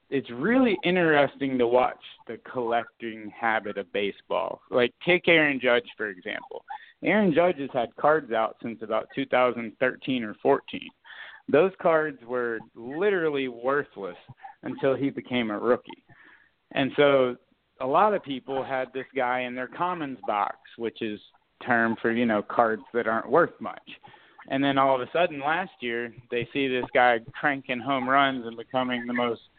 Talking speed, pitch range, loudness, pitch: 160 wpm, 120-145 Hz, -26 LUFS, 130 Hz